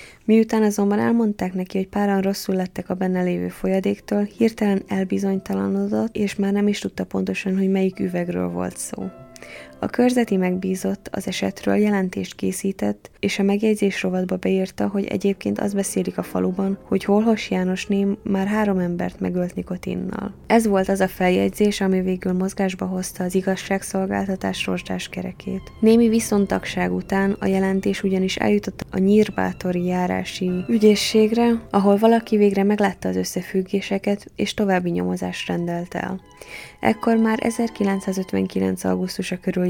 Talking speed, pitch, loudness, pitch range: 140 wpm, 190 Hz, -21 LUFS, 180-205 Hz